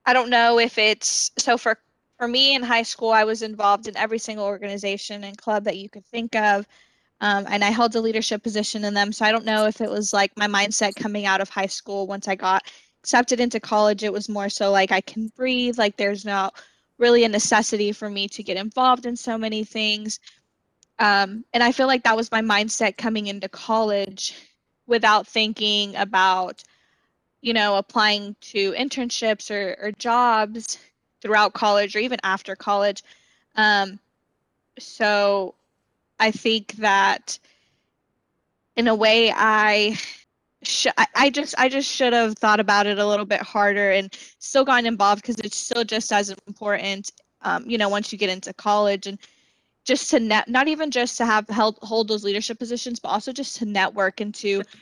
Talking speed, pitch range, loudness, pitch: 185 wpm, 205-230 Hz, -21 LUFS, 215 Hz